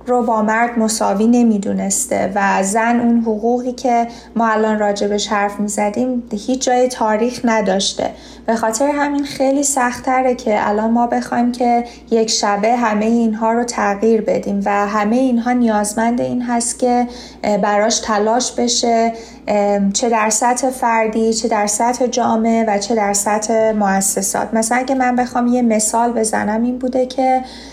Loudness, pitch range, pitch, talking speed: -16 LUFS, 215-245 Hz, 230 Hz, 145 wpm